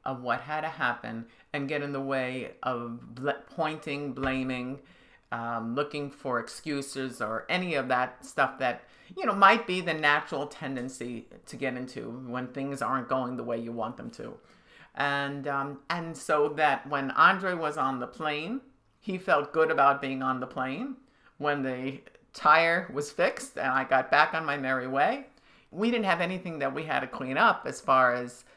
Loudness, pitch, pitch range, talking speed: -28 LUFS, 140 Hz, 130-160 Hz, 185 wpm